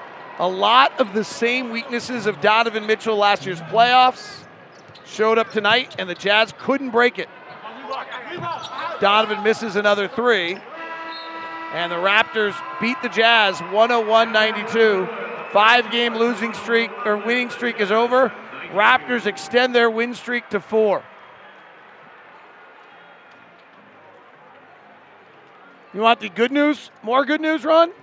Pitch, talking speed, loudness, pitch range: 230 Hz, 125 wpm, -19 LUFS, 210-245 Hz